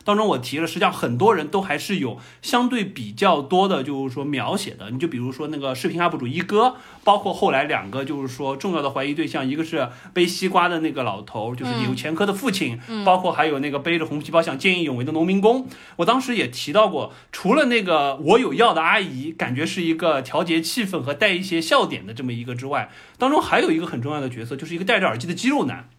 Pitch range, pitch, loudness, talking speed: 135-190 Hz, 165 Hz, -21 LUFS, 365 characters per minute